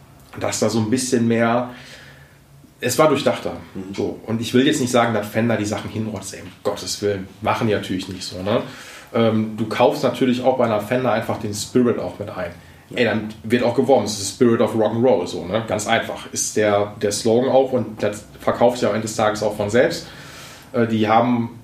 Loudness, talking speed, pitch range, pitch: -20 LUFS, 215 wpm, 105-125 Hz, 110 Hz